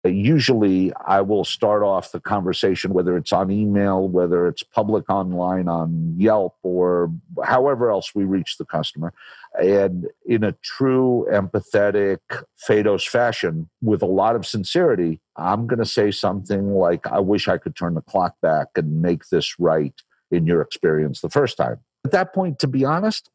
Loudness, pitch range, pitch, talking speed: -20 LUFS, 85-105 Hz, 95 Hz, 170 wpm